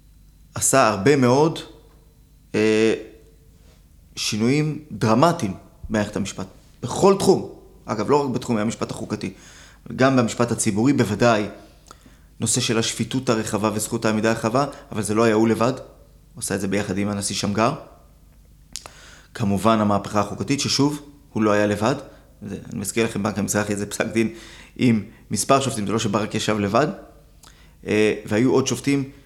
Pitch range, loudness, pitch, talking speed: 105-125 Hz, -21 LUFS, 110 Hz, 140 wpm